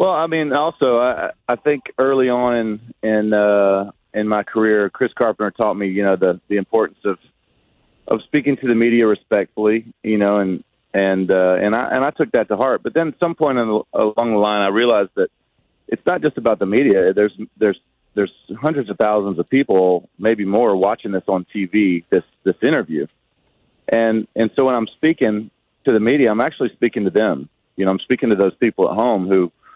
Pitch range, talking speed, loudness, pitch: 100-120 Hz, 210 wpm, -18 LUFS, 105 Hz